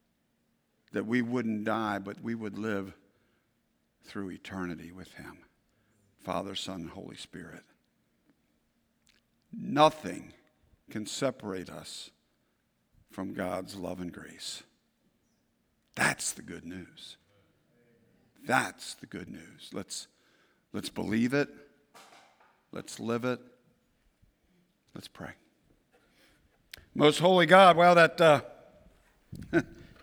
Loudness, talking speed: -28 LUFS, 100 wpm